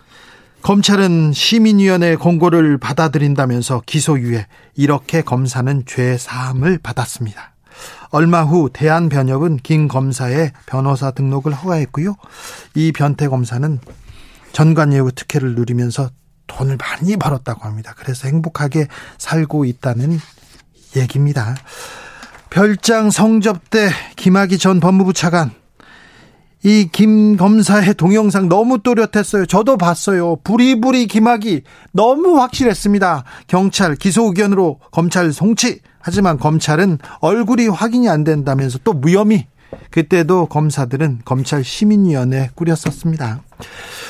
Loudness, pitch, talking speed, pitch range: -14 LUFS, 160 Hz, 285 characters per minute, 135-195 Hz